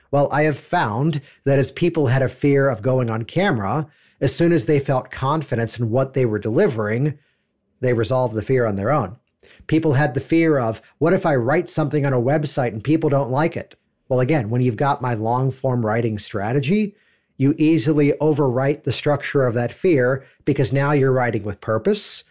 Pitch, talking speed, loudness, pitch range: 140 Hz, 200 wpm, -20 LUFS, 125-150 Hz